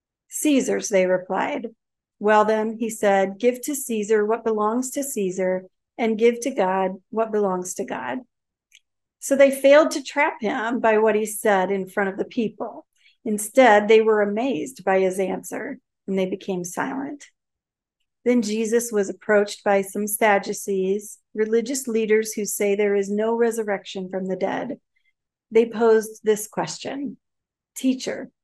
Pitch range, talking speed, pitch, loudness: 200-235 Hz, 150 wpm, 215 Hz, -22 LUFS